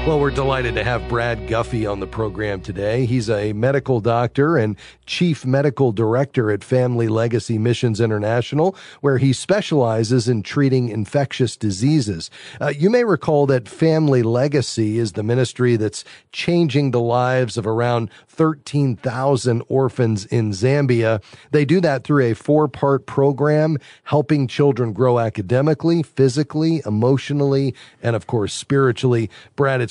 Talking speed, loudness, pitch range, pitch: 140 wpm, -19 LUFS, 115-145 Hz, 125 Hz